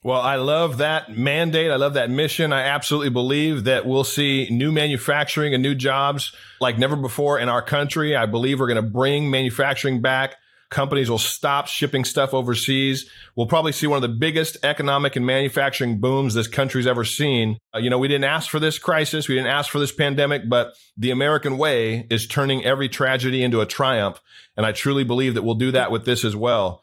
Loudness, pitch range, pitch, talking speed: -20 LUFS, 125-145 Hz, 135 Hz, 205 wpm